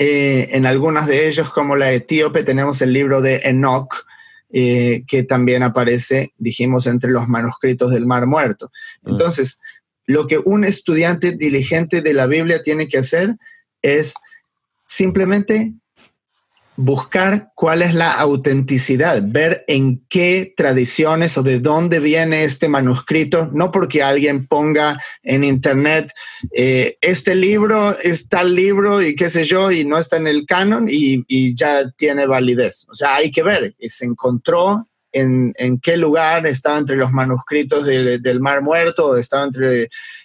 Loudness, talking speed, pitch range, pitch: -15 LUFS, 155 wpm, 130-175 Hz, 150 Hz